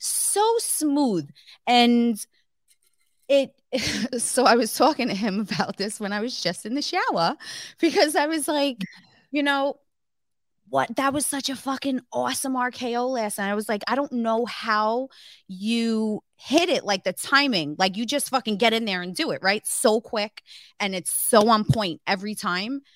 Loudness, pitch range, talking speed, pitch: -23 LUFS, 210-275 Hz, 180 wpm, 235 Hz